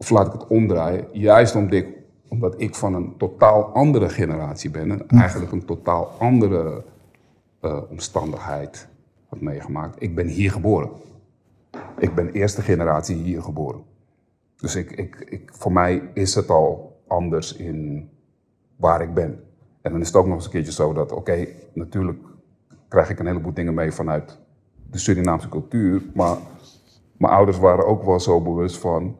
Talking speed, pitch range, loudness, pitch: 170 wpm, 85-105 Hz, -21 LUFS, 95 Hz